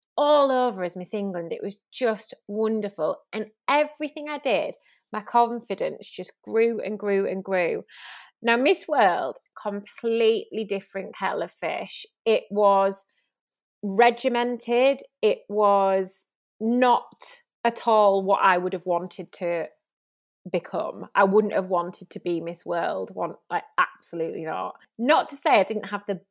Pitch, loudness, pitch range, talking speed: 215 Hz, -24 LUFS, 195-245 Hz, 145 wpm